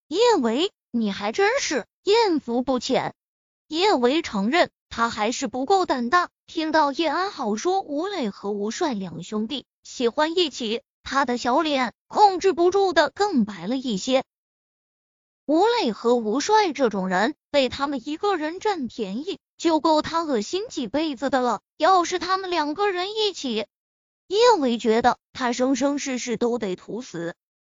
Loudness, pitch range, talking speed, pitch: -23 LUFS, 235-355 Hz, 220 characters per minute, 275 Hz